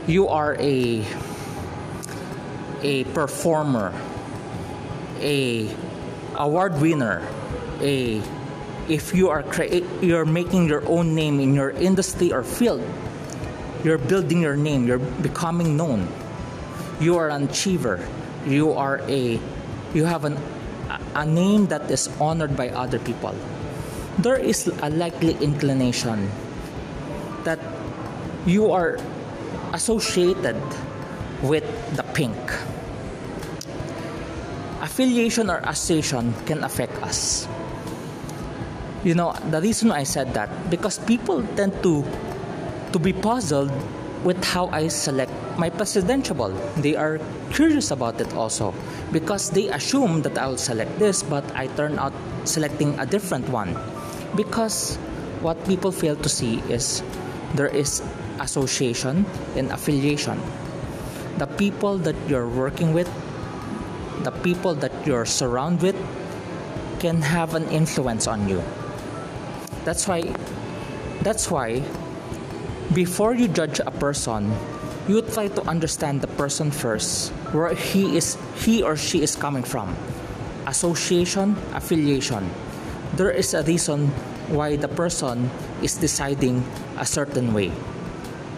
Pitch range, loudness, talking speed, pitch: 135-175 Hz, -24 LUFS, 120 wpm, 150 Hz